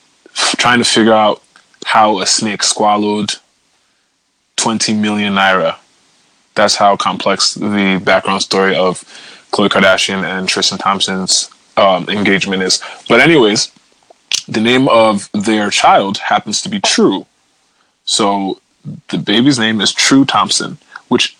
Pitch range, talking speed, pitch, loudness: 95-110 Hz, 125 wpm, 105 Hz, -12 LUFS